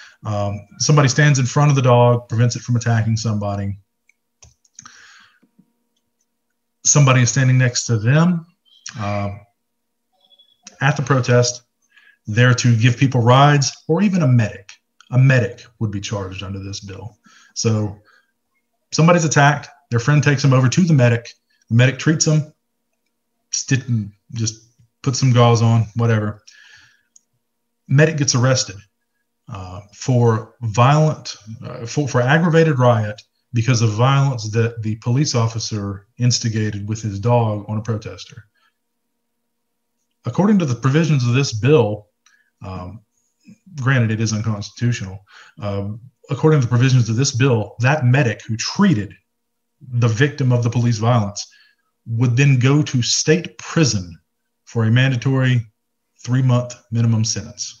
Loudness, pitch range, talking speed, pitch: -17 LUFS, 110-145 Hz, 135 wpm, 125 Hz